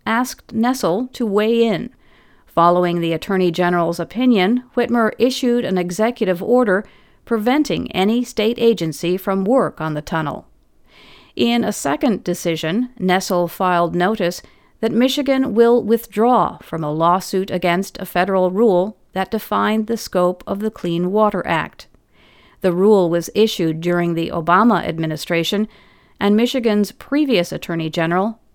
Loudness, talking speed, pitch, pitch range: -18 LUFS, 135 wpm, 195 Hz, 175-230 Hz